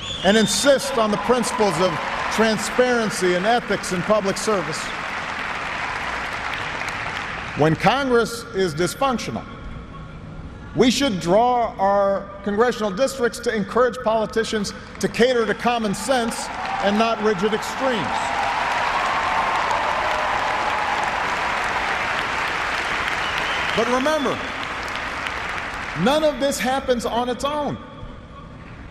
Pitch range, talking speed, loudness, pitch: 195-245 Hz, 90 wpm, -21 LUFS, 220 Hz